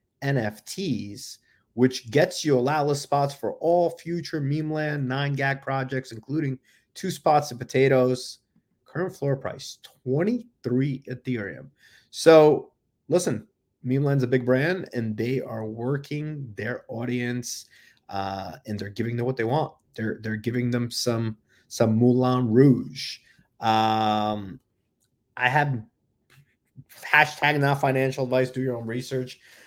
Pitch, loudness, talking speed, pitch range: 130 Hz, -25 LUFS, 130 wpm, 115-140 Hz